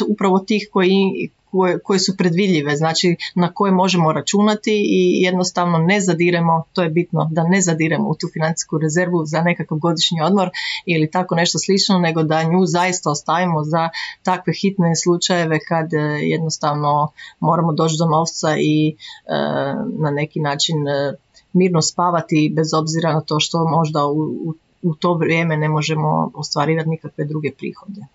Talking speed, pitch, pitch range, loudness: 160 wpm, 165 Hz, 155-180 Hz, -18 LUFS